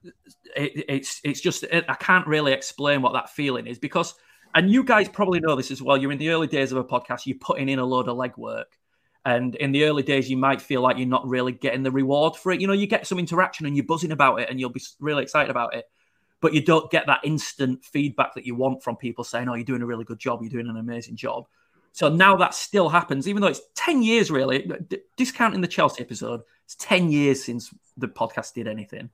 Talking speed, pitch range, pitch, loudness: 250 wpm, 130-170 Hz, 140 Hz, -23 LUFS